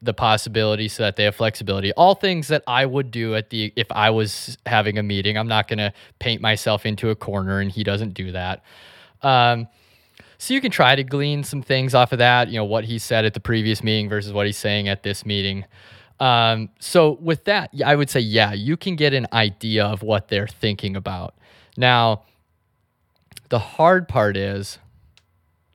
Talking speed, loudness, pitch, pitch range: 200 wpm, -20 LUFS, 110 Hz, 100-125 Hz